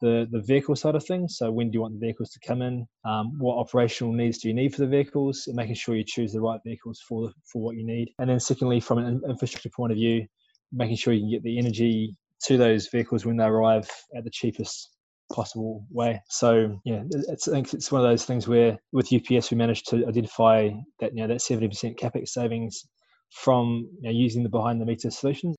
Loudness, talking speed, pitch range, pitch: -26 LUFS, 235 wpm, 115-125 Hz, 115 Hz